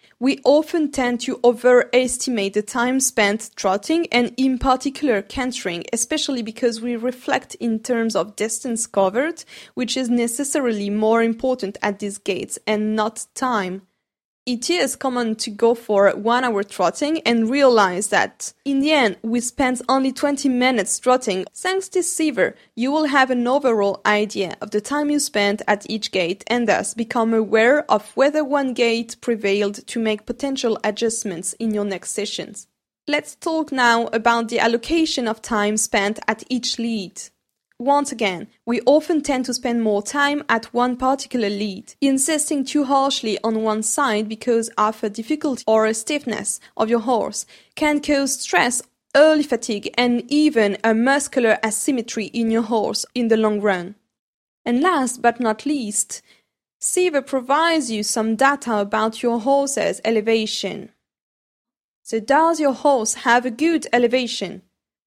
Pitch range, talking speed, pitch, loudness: 215-270 Hz, 155 wpm, 235 Hz, -20 LUFS